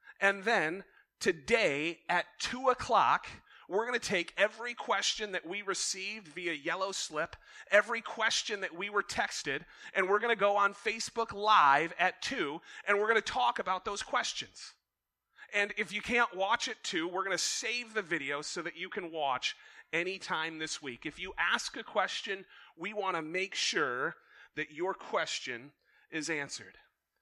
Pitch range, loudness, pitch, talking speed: 170-220 Hz, -32 LUFS, 195 Hz, 170 wpm